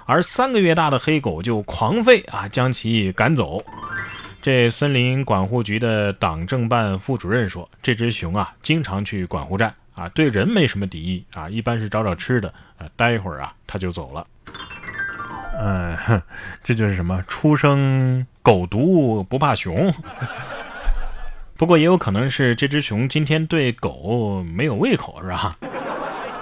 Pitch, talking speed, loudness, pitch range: 115 Hz, 230 characters per minute, -20 LUFS, 95-140 Hz